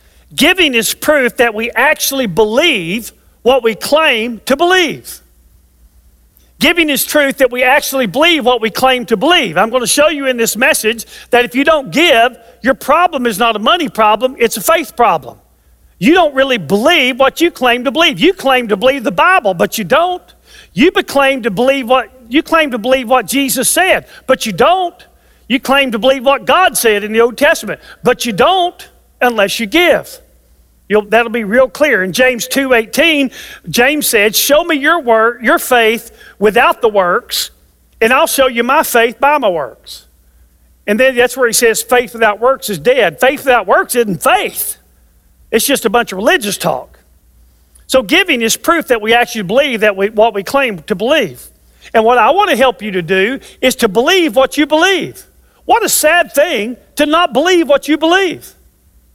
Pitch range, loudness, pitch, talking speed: 225-295 Hz, -11 LUFS, 255 Hz, 195 wpm